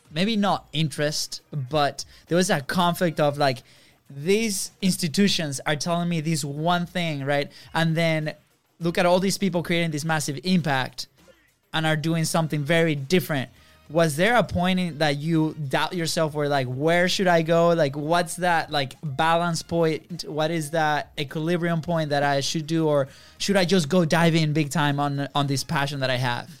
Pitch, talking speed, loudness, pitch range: 160 Hz, 185 wpm, -23 LUFS, 145-175 Hz